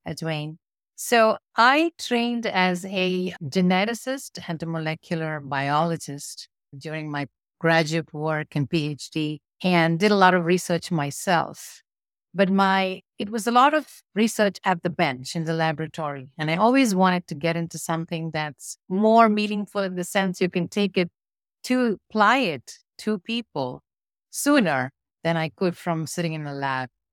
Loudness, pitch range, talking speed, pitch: -23 LUFS, 155-205 Hz, 155 wpm, 175 Hz